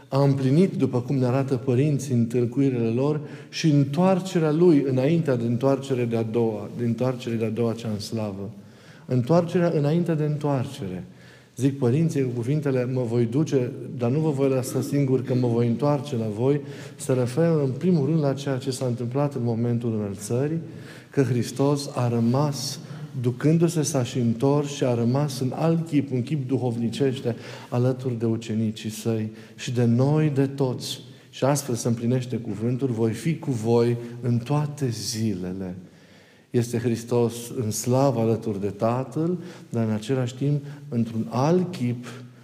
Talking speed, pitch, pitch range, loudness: 155 wpm, 130 Hz, 120-145 Hz, -24 LUFS